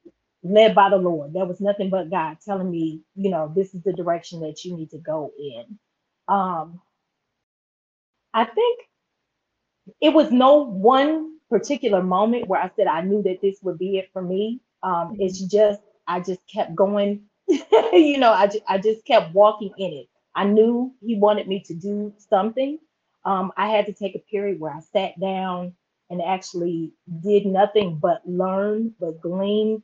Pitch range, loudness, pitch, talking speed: 180-215 Hz, -21 LUFS, 195 Hz, 175 wpm